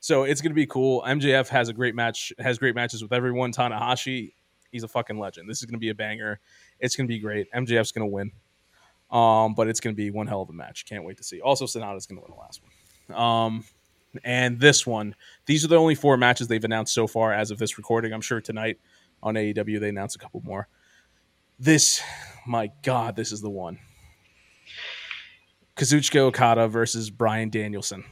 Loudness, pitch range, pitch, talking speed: -24 LUFS, 105-125 Hz, 115 Hz, 215 wpm